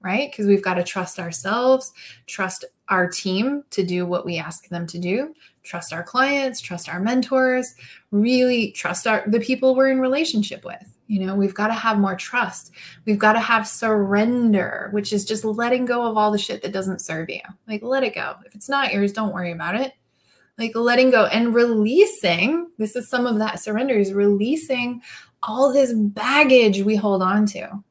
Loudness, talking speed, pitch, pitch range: -20 LUFS, 195 wpm, 220 Hz, 195-255 Hz